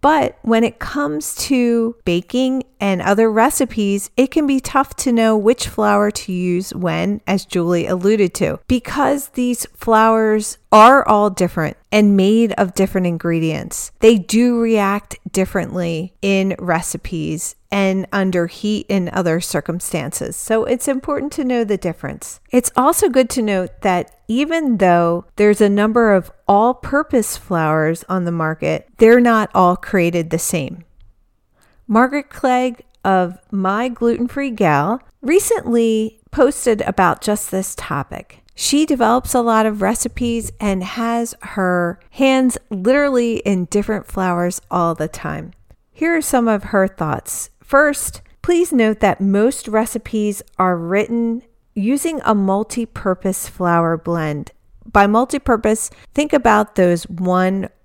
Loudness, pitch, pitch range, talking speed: -17 LUFS, 210 Hz, 185-245 Hz, 140 wpm